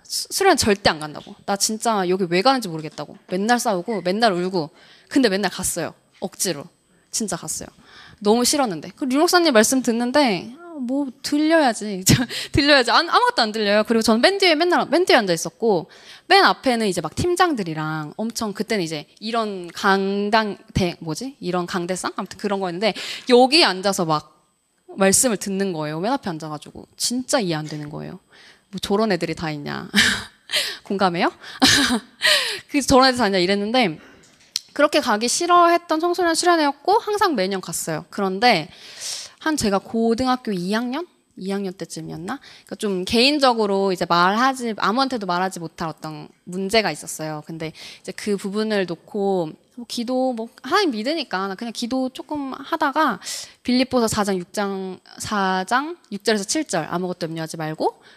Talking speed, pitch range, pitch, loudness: 335 characters per minute, 180-260 Hz, 210 Hz, -20 LUFS